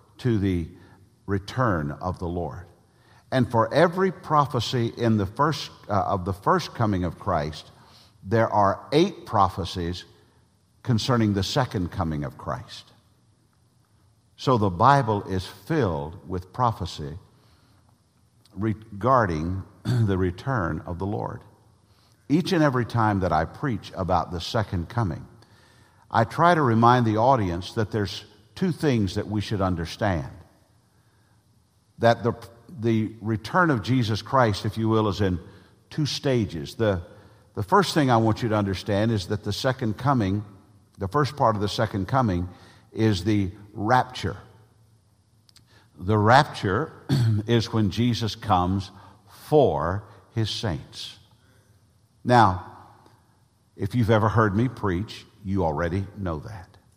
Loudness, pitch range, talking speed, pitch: -24 LUFS, 100-120 Hz, 135 wpm, 110 Hz